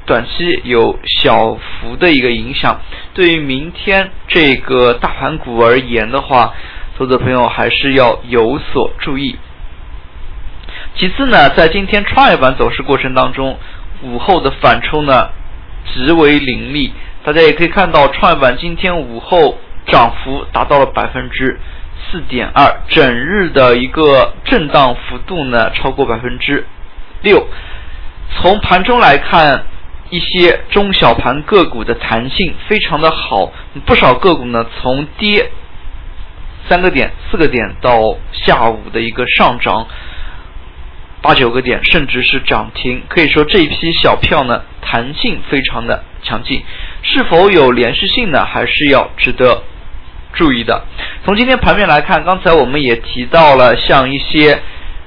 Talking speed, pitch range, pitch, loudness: 215 characters per minute, 95-155 Hz, 125 Hz, -11 LUFS